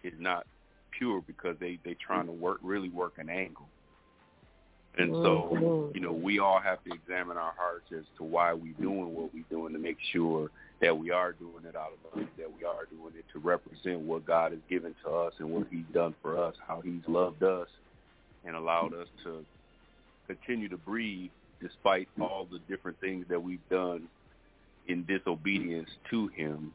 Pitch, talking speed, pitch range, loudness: 85 Hz, 190 wpm, 80-90 Hz, -33 LUFS